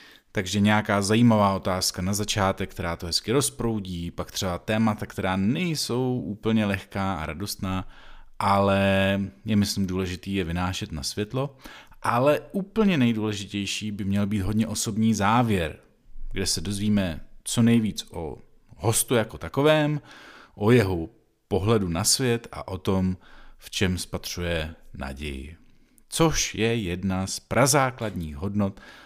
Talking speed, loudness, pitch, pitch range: 130 wpm, -25 LUFS, 100 Hz, 95-110 Hz